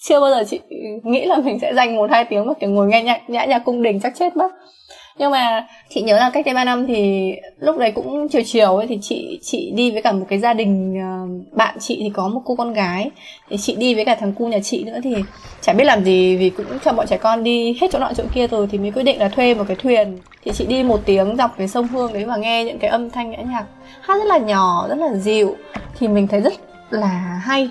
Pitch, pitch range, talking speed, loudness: 230 Hz, 205-255 Hz, 275 wpm, -18 LUFS